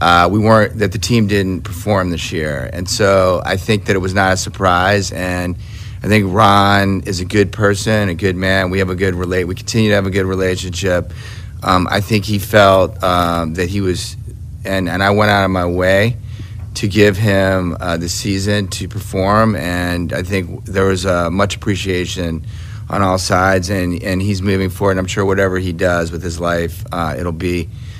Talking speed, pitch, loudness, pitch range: 205 wpm, 95 Hz, -15 LUFS, 90-105 Hz